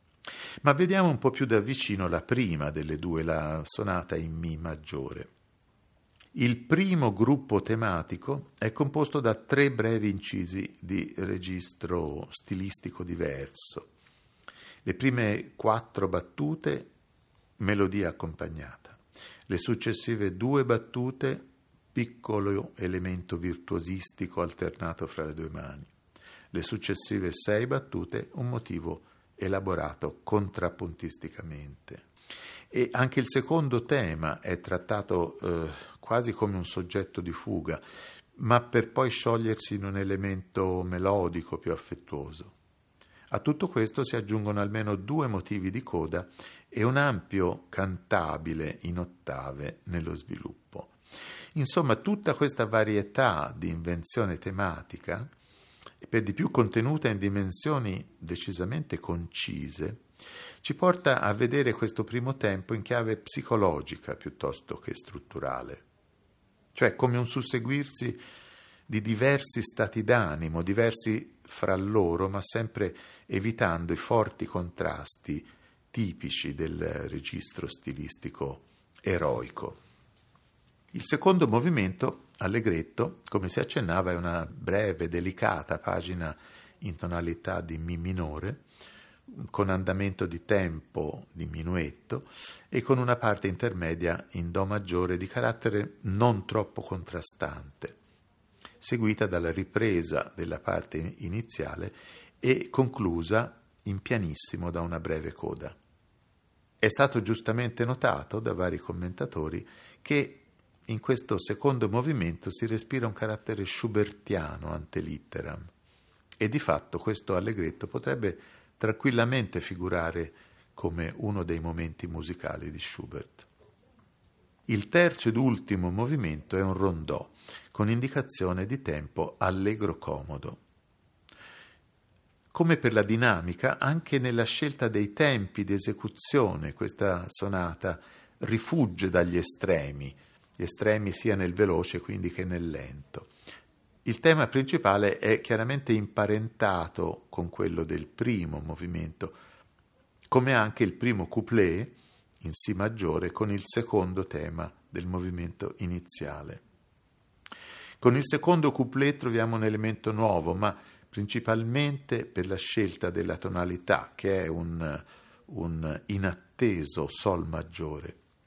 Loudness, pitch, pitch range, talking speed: -30 LUFS, 100 Hz, 85-115 Hz, 115 wpm